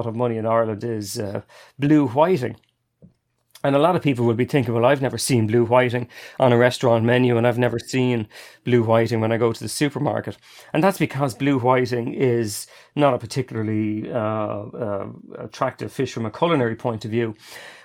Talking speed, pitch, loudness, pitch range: 190 wpm, 120 Hz, -21 LUFS, 115-130 Hz